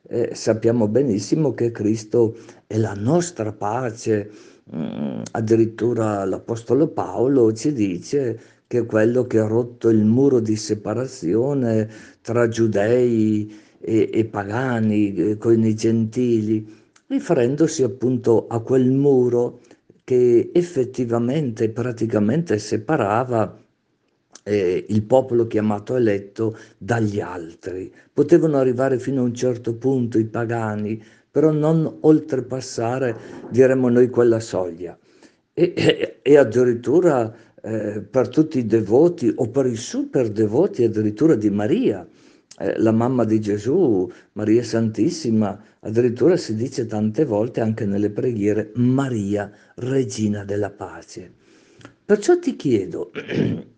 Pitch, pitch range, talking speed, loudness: 115 Hz, 110-130 Hz, 115 wpm, -20 LUFS